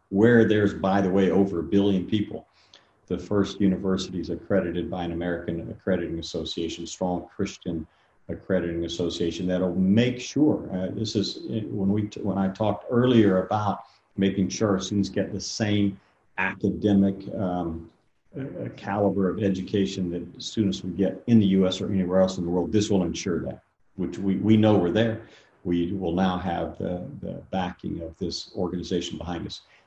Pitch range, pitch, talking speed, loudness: 90-105 Hz, 95 Hz, 170 wpm, -25 LUFS